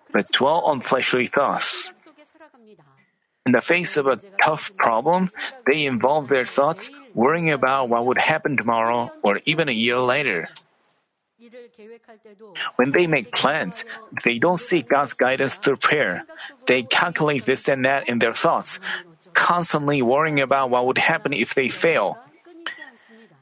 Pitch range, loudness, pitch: 130-210 Hz, -20 LUFS, 155 Hz